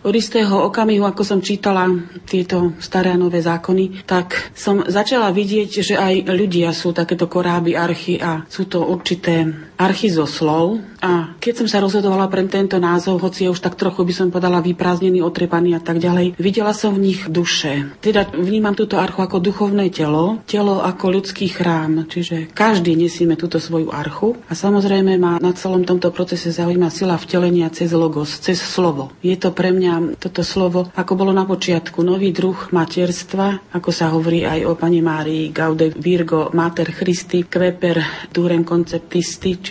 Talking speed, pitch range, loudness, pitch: 170 wpm, 170-190 Hz, -17 LUFS, 180 Hz